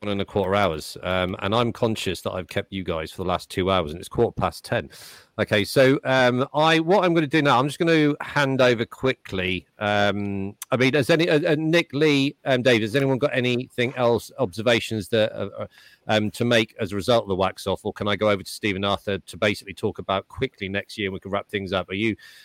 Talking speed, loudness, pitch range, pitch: 250 wpm, -23 LUFS, 100-130 Hz, 110 Hz